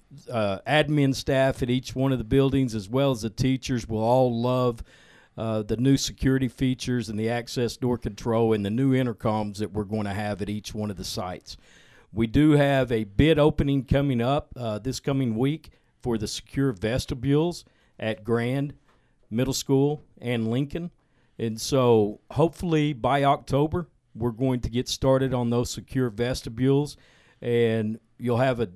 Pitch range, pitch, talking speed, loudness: 115-135 Hz, 125 Hz, 170 wpm, -25 LUFS